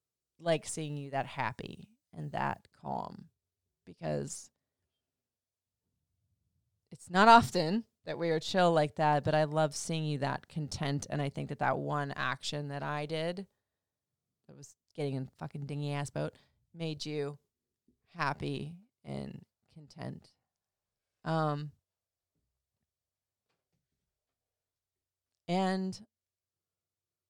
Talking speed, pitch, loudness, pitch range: 110 wpm, 145 Hz, -33 LUFS, 100-160 Hz